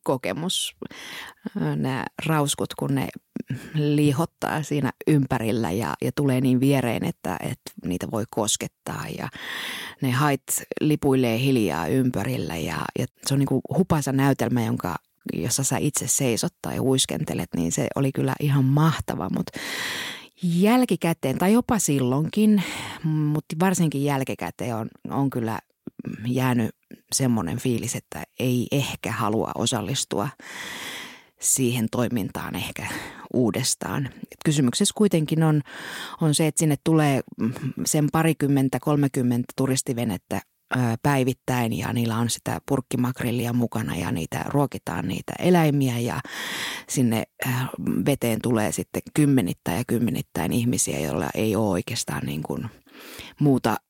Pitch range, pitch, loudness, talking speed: 120-150 Hz, 130 Hz, -24 LUFS, 120 wpm